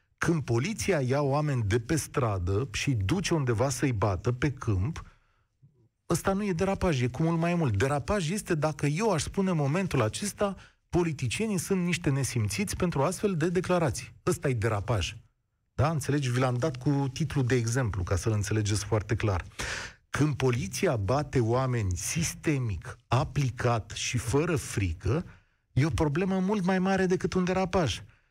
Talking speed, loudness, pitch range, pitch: 160 wpm, -29 LUFS, 115-170 Hz, 135 Hz